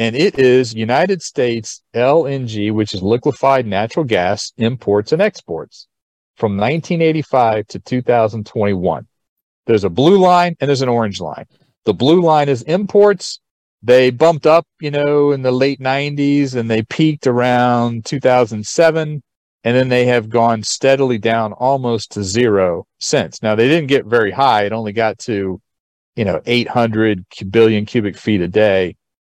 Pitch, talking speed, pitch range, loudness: 120 Hz, 155 wpm, 110-140 Hz, -15 LUFS